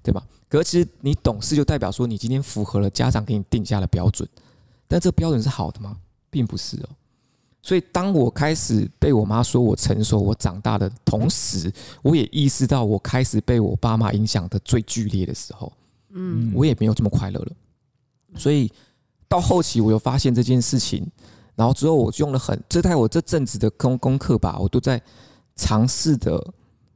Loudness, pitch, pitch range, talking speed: -21 LUFS, 120 Hz, 110-135 Hz, 285 characters per minute